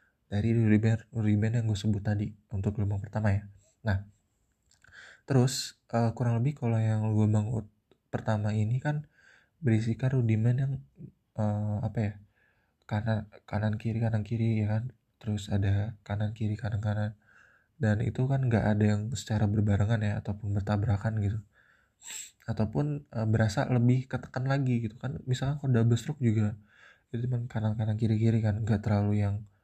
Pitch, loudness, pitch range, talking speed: 110 Hz, -30 LUFS, 105-120 Hz, 145 wpm